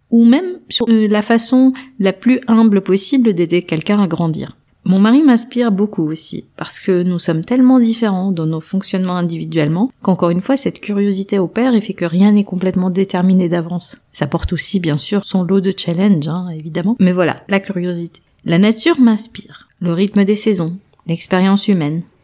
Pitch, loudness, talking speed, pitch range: 195 Hz, -15 LUFS, 180 wpm, 175-220 Hz